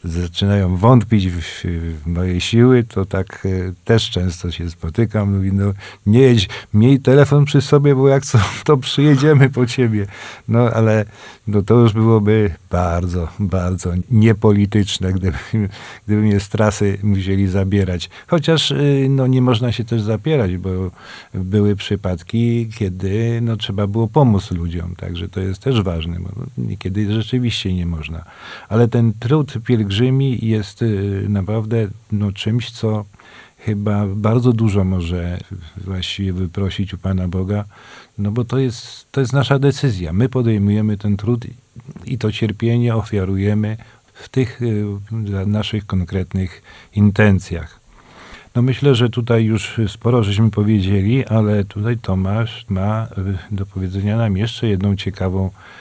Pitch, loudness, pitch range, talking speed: 105 Hz, -17 LUFS, 95-115 Hz, 140 wpm